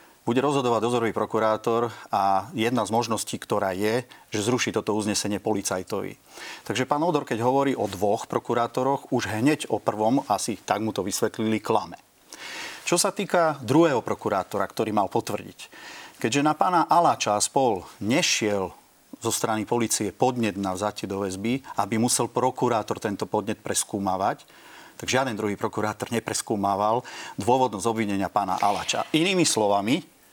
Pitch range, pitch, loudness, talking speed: 105-130 Hz, 115 Hz, -25 LUFS, 140 wpm